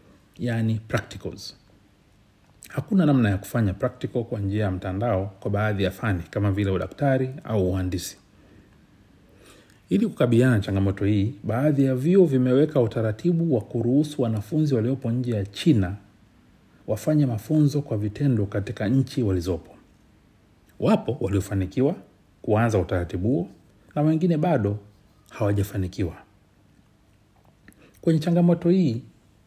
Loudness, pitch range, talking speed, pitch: -24 LUFS, 100-130 Hz, 110 wpm, 105 Hz